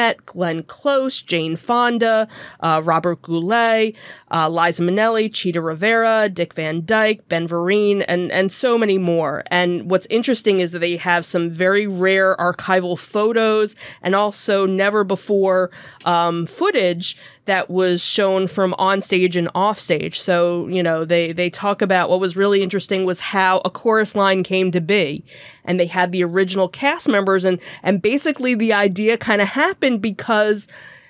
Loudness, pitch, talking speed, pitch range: -18 LUFS, 190 Hz, 160 wpm, 175-210 Hz